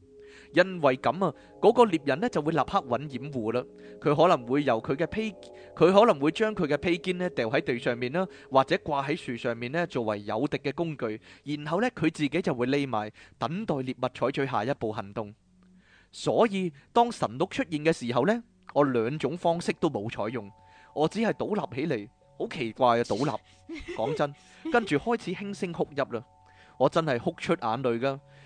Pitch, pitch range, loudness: 145 Hz, 120-180 Hz, -28 LUFS